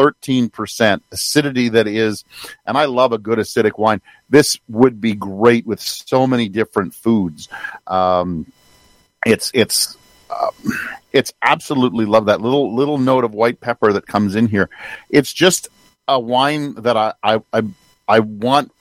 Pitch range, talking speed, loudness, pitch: 105-125 Hz, 155 wpm, -16 LUFS, 115 Hz